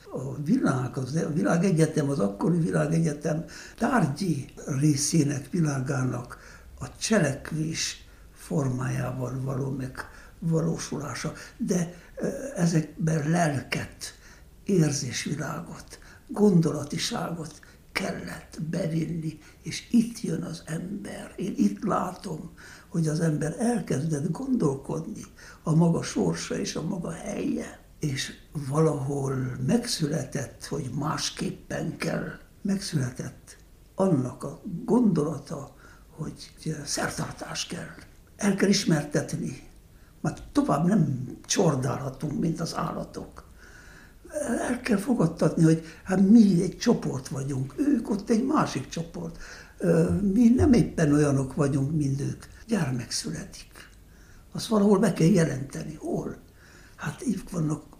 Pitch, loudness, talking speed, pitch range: 160 Hz, -27 LUFS, 100 wpm, 140-190 Hz